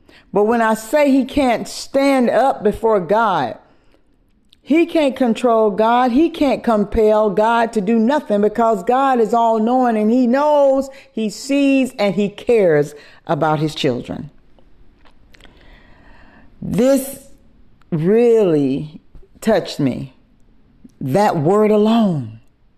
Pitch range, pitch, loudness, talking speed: 210-270 Hz, 225 Hz, -16 LUFS, 115 wpm